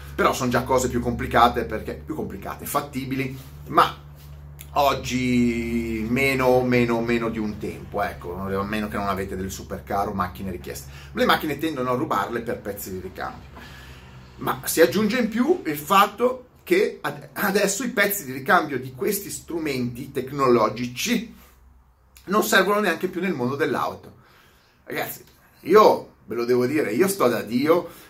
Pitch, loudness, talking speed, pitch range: 120 Hz, -23 LUFS, 155 wpm, 95-160 Hz